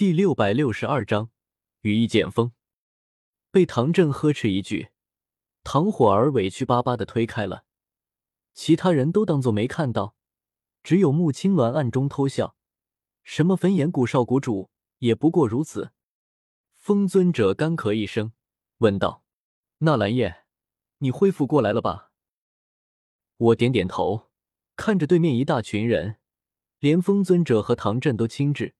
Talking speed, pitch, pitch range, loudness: 210 characters per minute, 125 Hz, 105-155 Hz, -22 LUFS